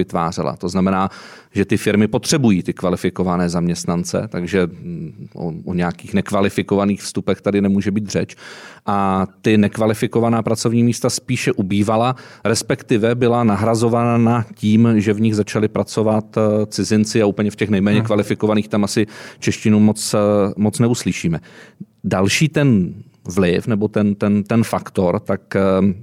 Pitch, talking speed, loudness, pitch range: 105 Hz, 135 wpm, -18 LUFS, 100-115 Hz